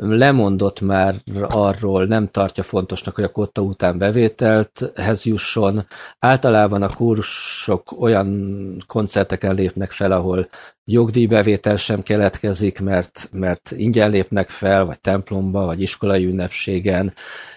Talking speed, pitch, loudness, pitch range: 115 wpm, 100 Hz, -18 LUFS, 95-105 Hz